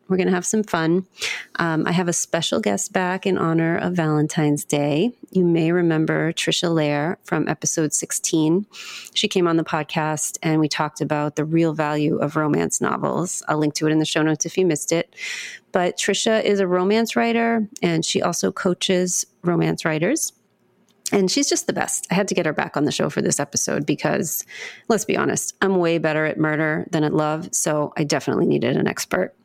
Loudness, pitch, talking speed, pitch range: -21 LUFS, 165 Hz, 205 wpm, 155-185 Hz